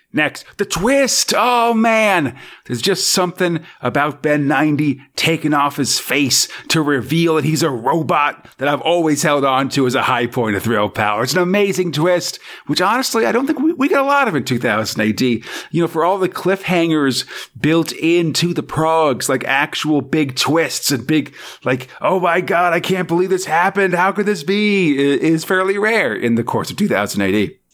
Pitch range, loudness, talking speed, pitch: 140-185 Hz, -16 LUFS, 195 wpm, 160 Hz